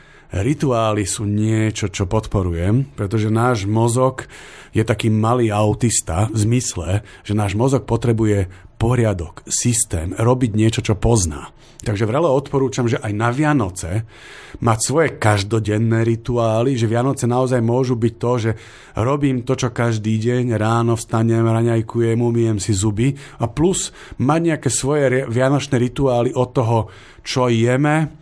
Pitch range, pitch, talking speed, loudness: 110-130 Hz, 115 Hz, 135 wpm, -18 LUFS